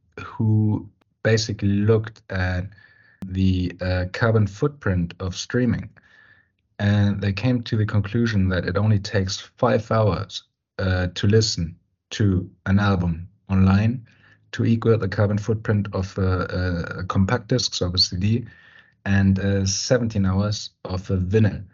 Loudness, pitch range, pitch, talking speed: -22 LUFS, 95-110 Hz, 100 Hz, 140 wpm